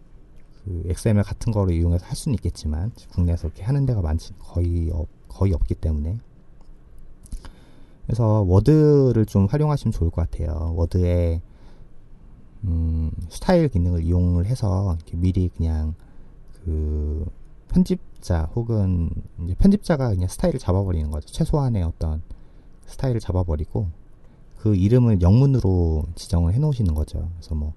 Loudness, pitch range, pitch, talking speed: -22 LUFS, 85-115 Hz, 90 Hz, 310 characters per minute